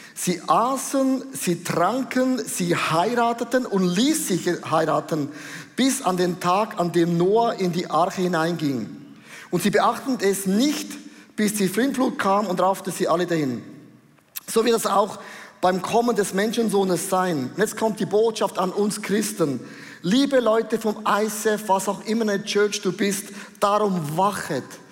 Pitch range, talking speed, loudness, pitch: 180-225 Hz, 155 wpm, -22 LUFS, 200 Hz